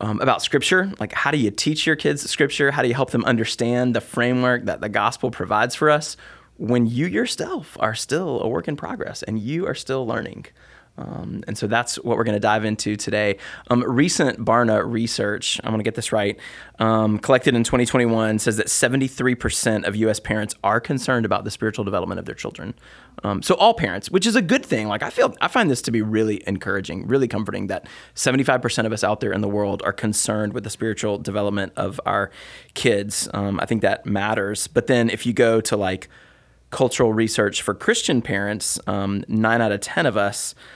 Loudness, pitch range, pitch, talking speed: -21 LUFS, 105-125 Hz, 110 Hz, 210 wpm